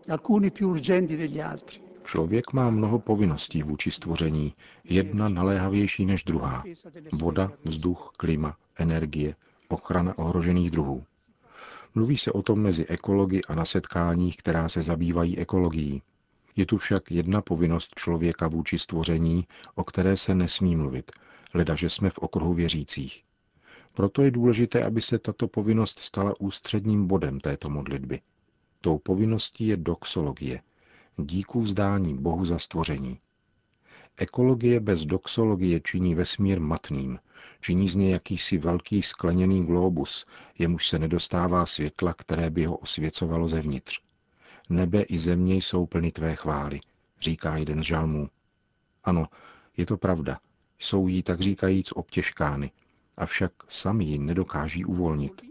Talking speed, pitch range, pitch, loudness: 125 wpm, 80-100 Hz, 90 Hz, -26 LUFS